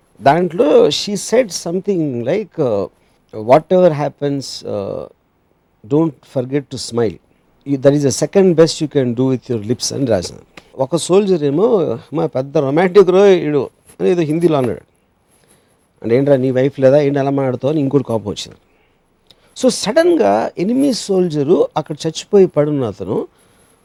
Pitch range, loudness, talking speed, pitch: 130-180 Hz, -15 LUFS, 145 wpm, 150 Hz